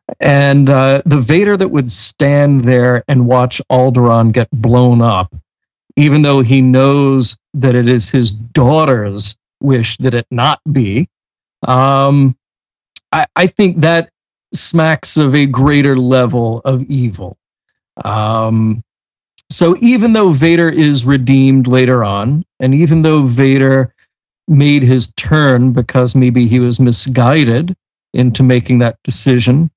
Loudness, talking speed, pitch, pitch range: -10 LUFS, 130 wpm, 130 Hz, 120-145 Hz